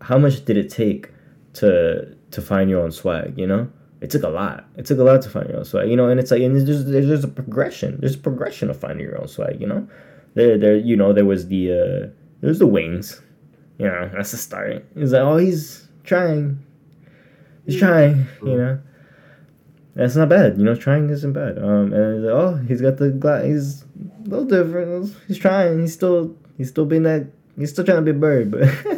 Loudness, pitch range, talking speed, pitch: -19 LUFS, 120-160 Hz, 225 wpm, 140 Hz